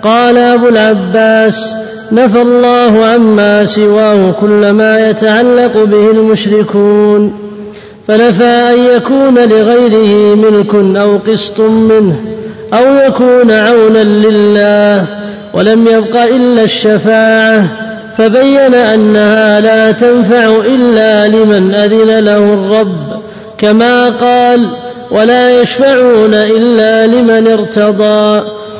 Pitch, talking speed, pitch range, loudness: 220 Hz, 90 wpm, 210-235 Hz, -6 LUFS